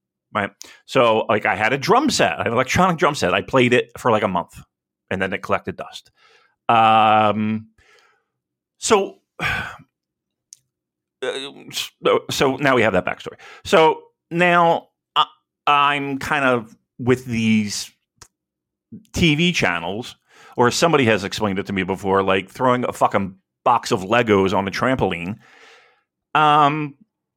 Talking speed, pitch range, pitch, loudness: 135 wpm, 95-145 Hz, 115 Hz, -19 LUFS